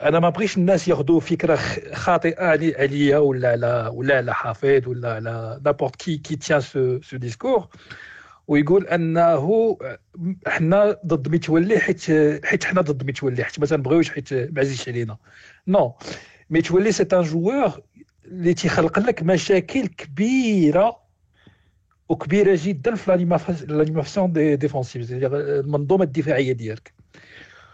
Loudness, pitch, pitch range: -20 LUFS, 155 Hz, 135-180 Hz